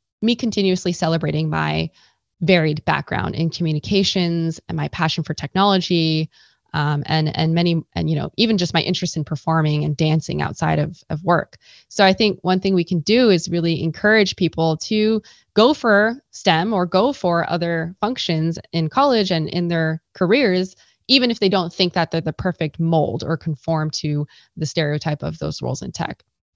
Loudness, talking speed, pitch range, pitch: -19 LUFS, 180 wpm, 160-190 Hz, 170 Hz